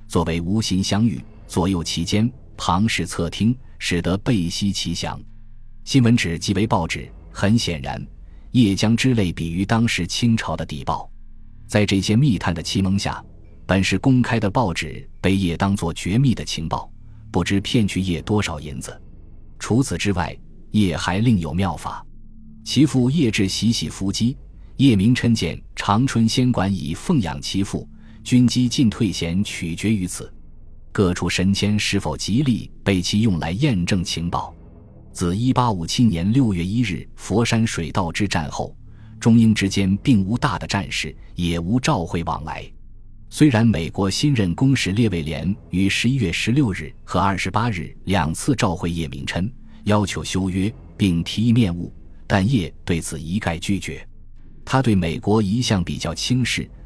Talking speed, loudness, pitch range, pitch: 235 characters per minute, -21 LUFS, 85-115 Hz, 100 Hz